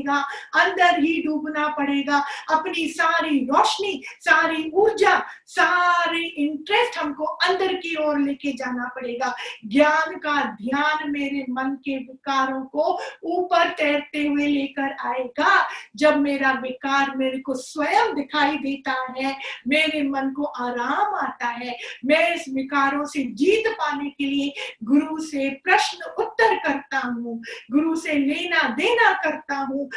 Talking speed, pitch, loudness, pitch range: 130 wpm, 290 Hz, -22 LUFS, 275-330 Hz